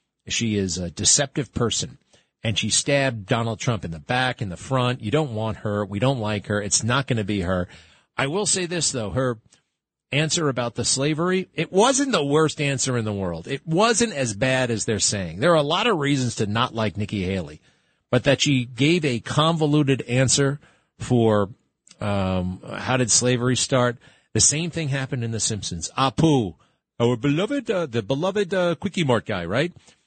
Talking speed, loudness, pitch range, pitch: 190 wpm, -22 LUFS, 110-150 Hz, 125 Hz